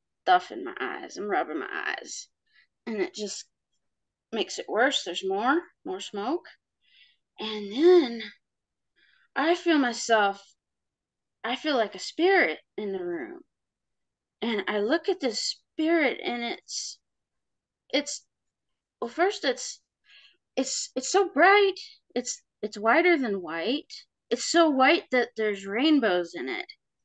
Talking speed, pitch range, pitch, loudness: 135 wpm, 220-345 Hz, 260 Hz, -26 LUFS